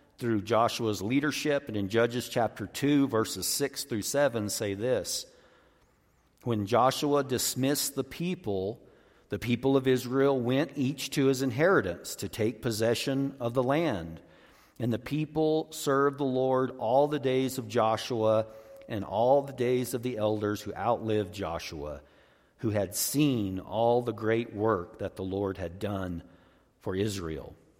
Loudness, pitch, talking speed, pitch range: -29 LUFS, 120 Hz, 150 wpm, 105-135 Hz